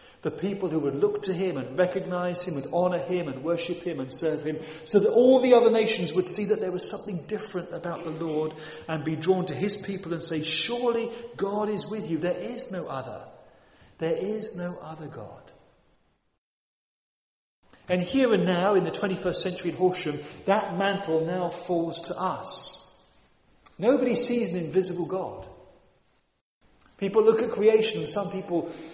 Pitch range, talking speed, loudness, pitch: 165-205 Hz, 175 wpm, -26 LUFS, 180 Hz